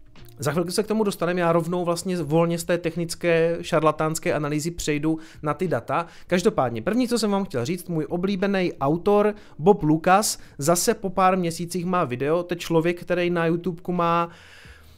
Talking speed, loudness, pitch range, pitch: 170 wpm, -23 LUFS, 160-185 Hz, 170 Hz